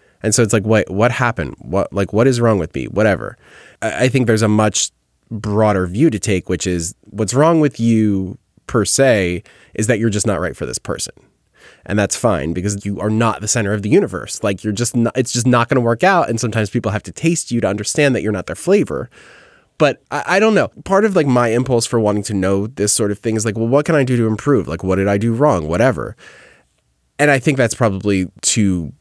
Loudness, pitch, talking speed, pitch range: -16 LUFS, 110 Hz, 240 wpm, 100-120 Hz